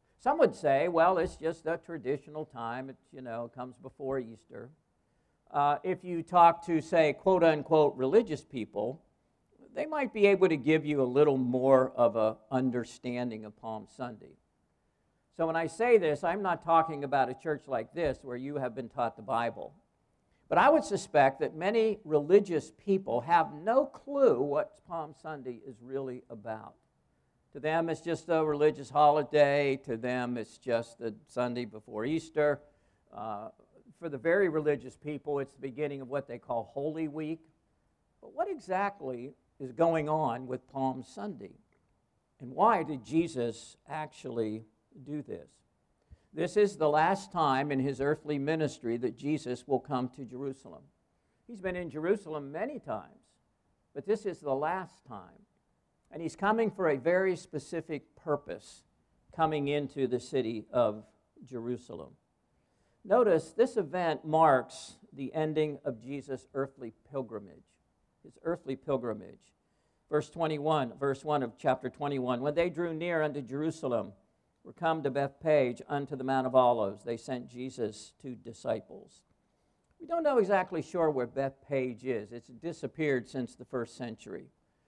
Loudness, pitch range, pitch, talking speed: -31 LUFS, 125-160 Hz, 145 Hz, 155 wpm